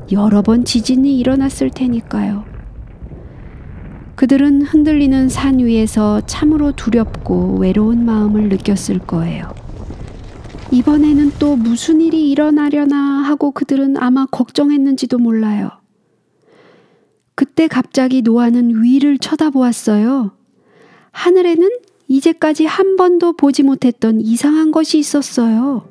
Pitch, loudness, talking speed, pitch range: 265 Hz, -13 LUFS, 265 characters per minute, 230-295 Hz